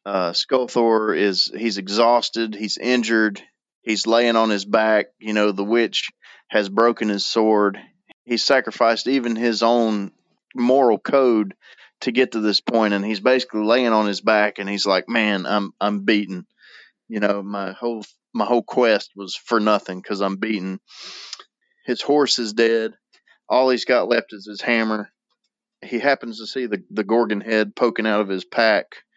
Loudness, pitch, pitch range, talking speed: -20 LUFS, 110 Hz, 105-115 Hz, 165 wpm